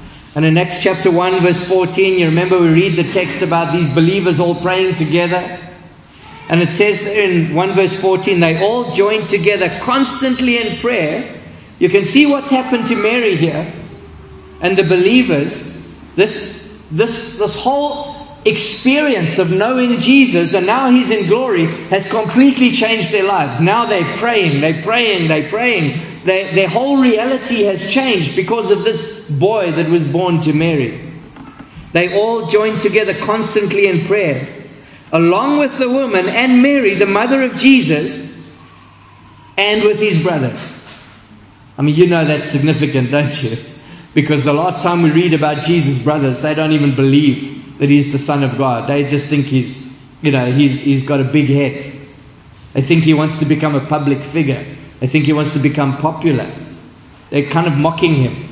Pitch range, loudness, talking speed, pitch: 150-210 Hz, -13 LUFS, 170 wpm, 175 Hz